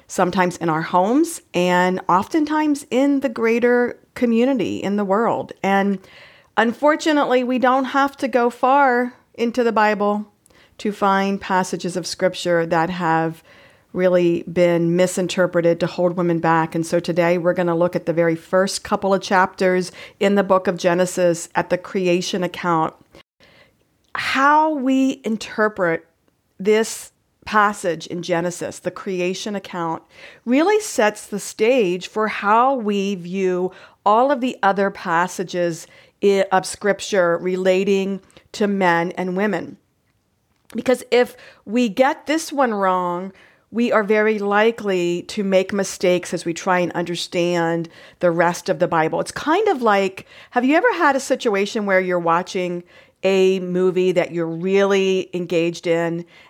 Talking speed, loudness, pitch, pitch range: 145 wpm, -19 LUFS, 190 Hz, 175-225 Hz